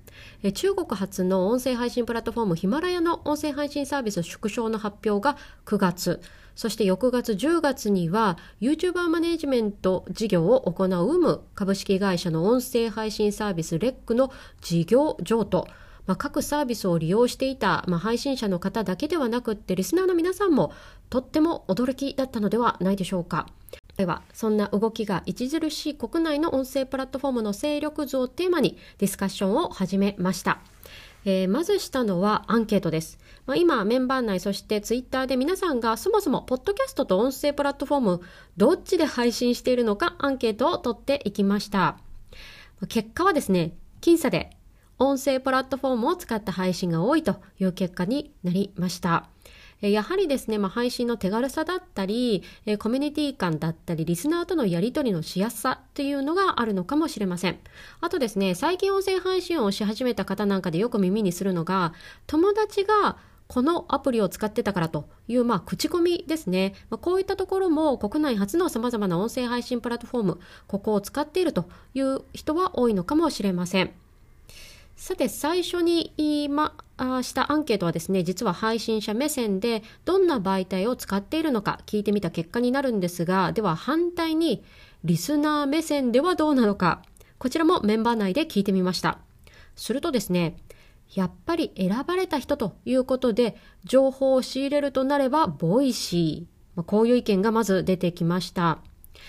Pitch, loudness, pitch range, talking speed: 230 Hz, -25 LUFS, 190-285 Hz, 375 characters per minute